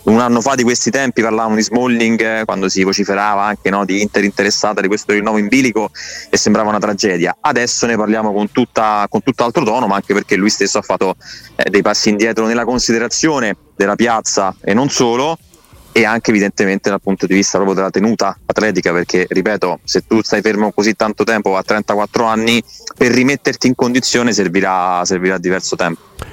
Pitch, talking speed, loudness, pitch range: 110 Hz, 190 wpm, -14 LUFS, 100-115 Hz